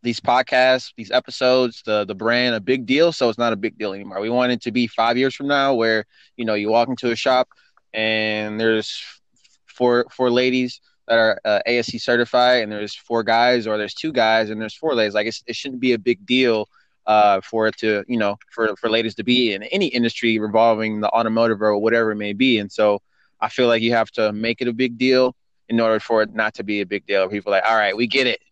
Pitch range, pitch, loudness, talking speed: 110-125 Hz, 115 Hz, -19 LUFS, 250 wpm